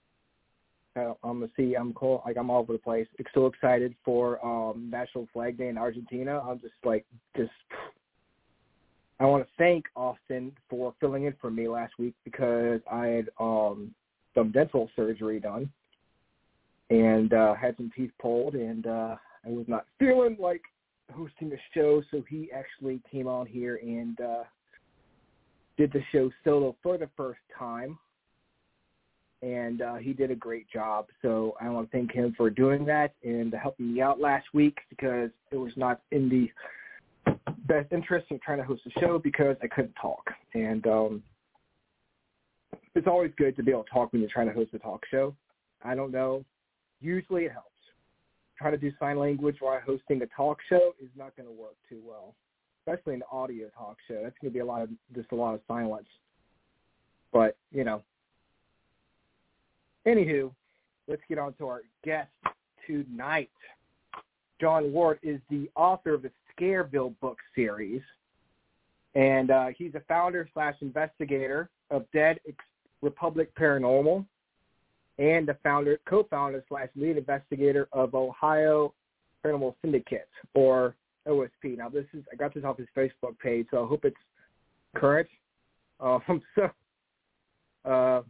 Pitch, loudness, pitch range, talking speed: 130 Hz, -29 LUFS, 120-145 Hz, 160 wpm